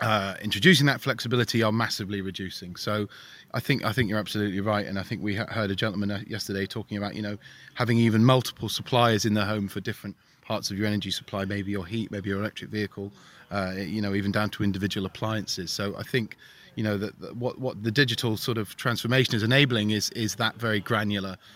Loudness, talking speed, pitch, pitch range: -27 LUFS, 215 wpm, 105 Hz, 100-115 Hz